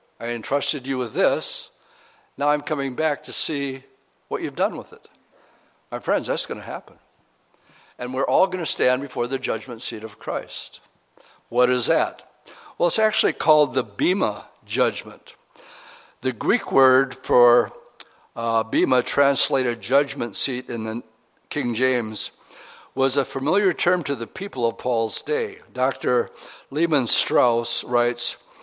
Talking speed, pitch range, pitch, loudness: 150 wpm, 120-175 Hz, 135 Hz, -22 LUFS